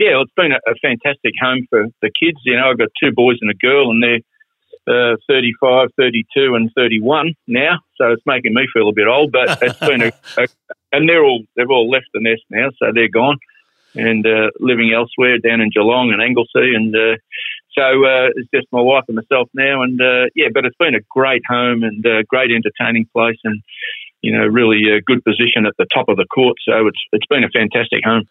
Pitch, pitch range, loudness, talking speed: 120 Hz, 115-130 Hz, -14 LUFS, 225 wpm